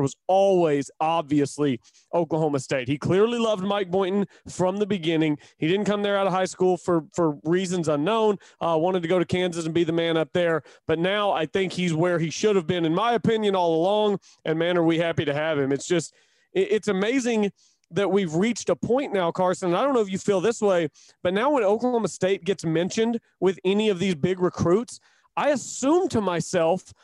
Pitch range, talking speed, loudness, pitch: 165-205 Hz, 220 wpm, -24 LUFS, 185 Hz